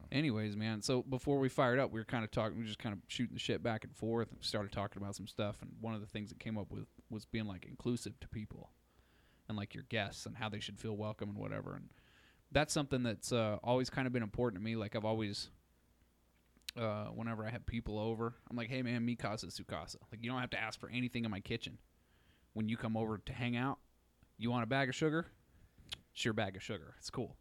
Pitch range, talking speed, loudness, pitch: 105-125 Hz, 250 wpm, -40 LUFS, 115 Hz